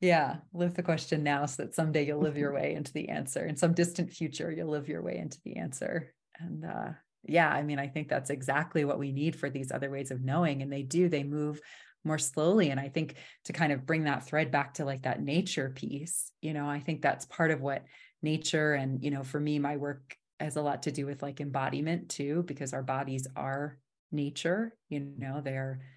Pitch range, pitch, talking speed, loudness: 140-160 Hz, 150 Hz, 230 wpm, -32 LUFS